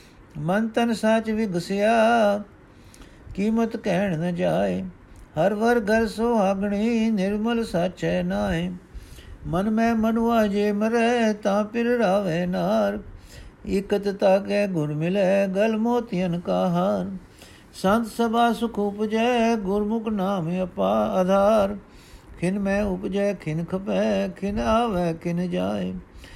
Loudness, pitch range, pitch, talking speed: -23 LUFS, 185-225 Hz, 200 Hz, 115 wpm